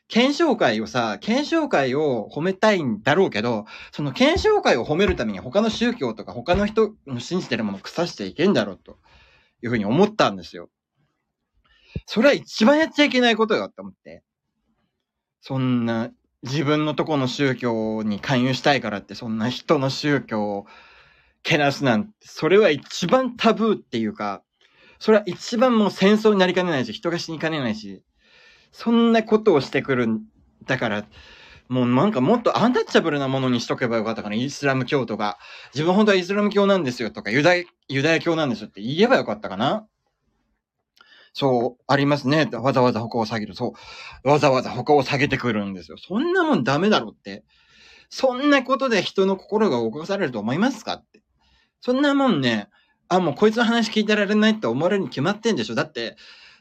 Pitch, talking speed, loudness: 155 Hz, 385 characters per minute, -21 LUFS